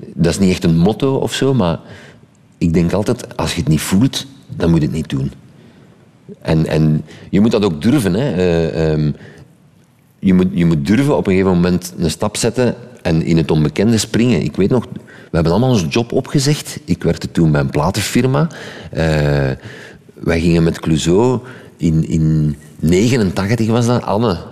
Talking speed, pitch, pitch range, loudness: 185 wpm, 90 Hz, 80-120 Hz, -15 LUFS